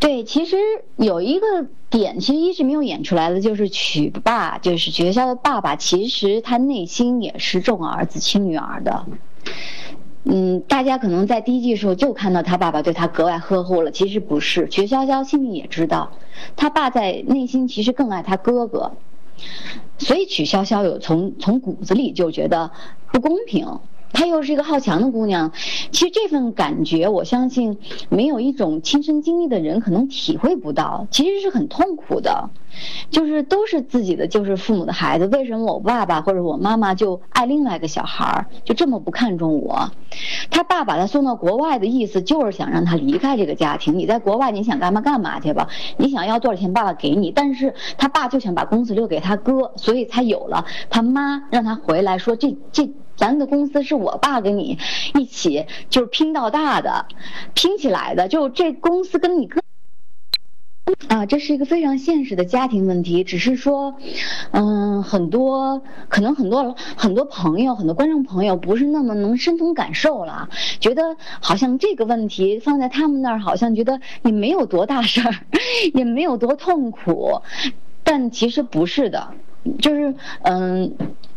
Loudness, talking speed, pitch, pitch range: -19 LUFS, 275 characters per minute, 245 Hz, 195-285 Hz